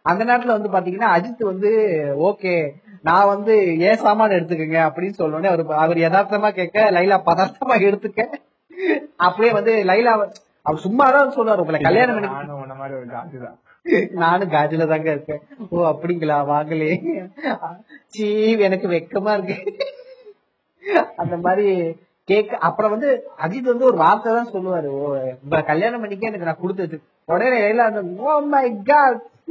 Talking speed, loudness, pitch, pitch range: 100 wpm, -18 LUFS, 195 Hz, 165-225 Hz